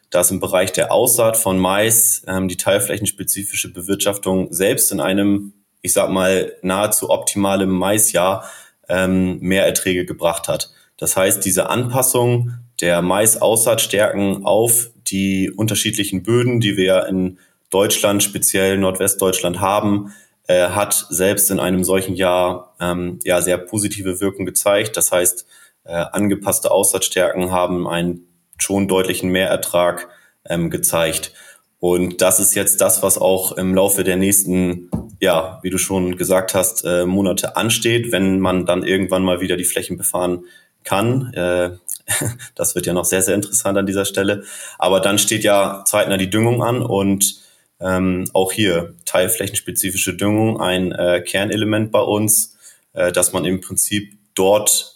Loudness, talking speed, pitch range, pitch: -17 LUFS, 145 wpm, 90-100 Hz, 95 Hz